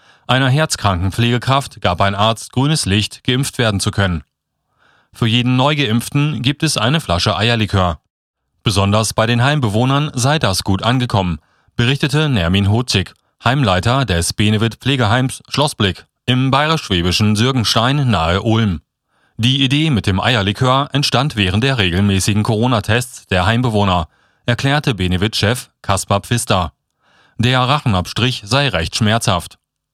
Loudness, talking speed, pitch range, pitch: -15 LUFS, 120 wpm, 100-130 Hz, 115 Hz